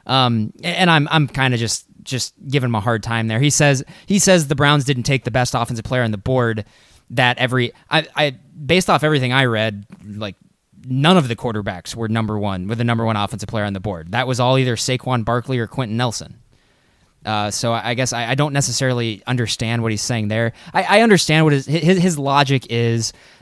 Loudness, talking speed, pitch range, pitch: -18 LUFS, 220 wpm, 115-140 Hz, 125 Hz